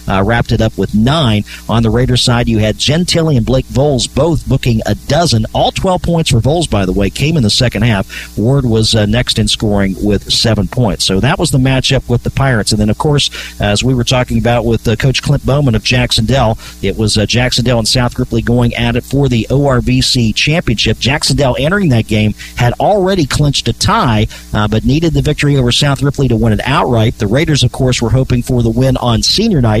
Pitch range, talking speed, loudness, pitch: 110-135 Hz, 235 wpm, -12 LUFS, 120 Hz